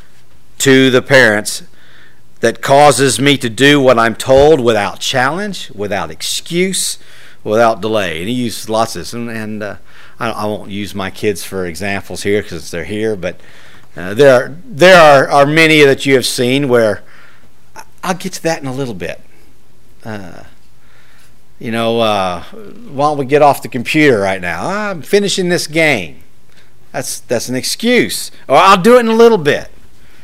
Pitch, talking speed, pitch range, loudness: 120 Hz, 175 wpm, 100-145 Hz, -12 LUFS